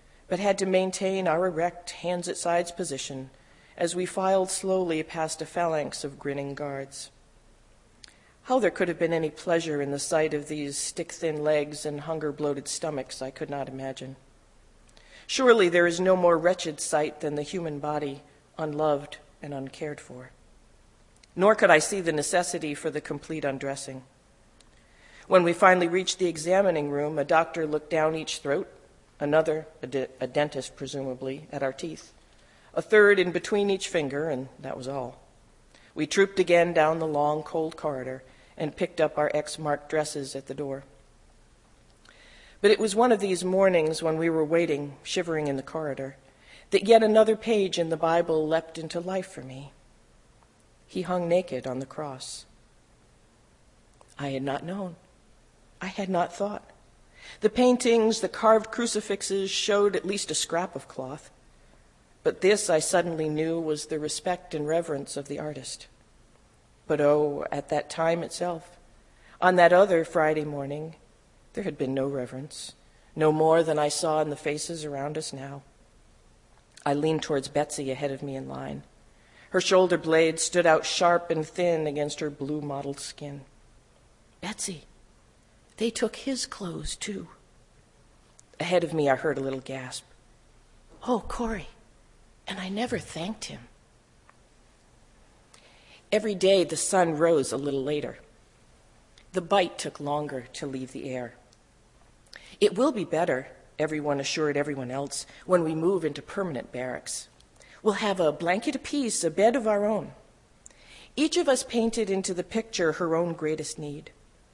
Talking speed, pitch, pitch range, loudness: 160 wpm, 155 Hz, 140-180 Hz, -27 LUFS